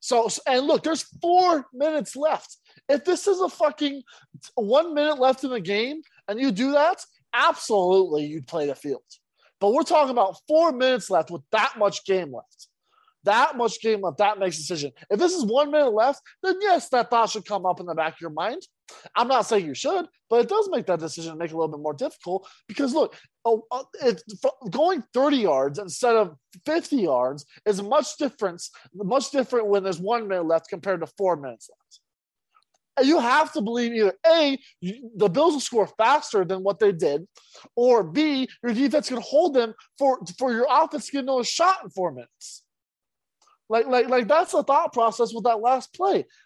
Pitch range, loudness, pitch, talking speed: 195-300 Hz, -23 LUFS, 240 Hz, 205 wpm